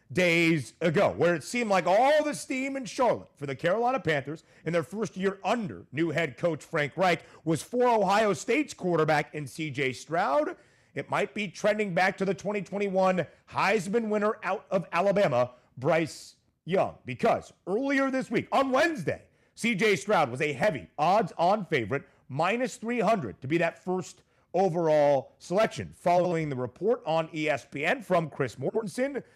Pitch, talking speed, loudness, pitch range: 175 Hz, 160 wpm, -28 LUFS, 155-210 Hz